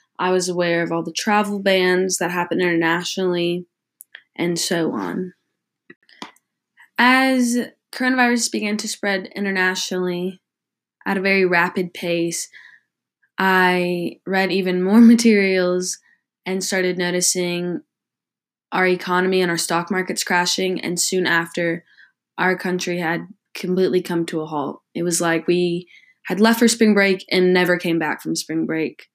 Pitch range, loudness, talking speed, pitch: 175-190 Hz, -19 LUFS, 140 wpm, 180 Hz